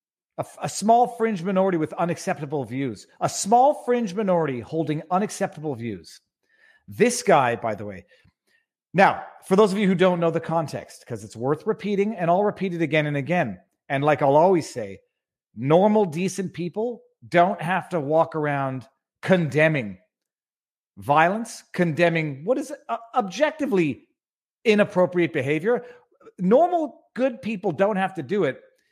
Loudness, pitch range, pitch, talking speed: -23 LUFS, 155-220 Hz, 180 Hz, 145 wpm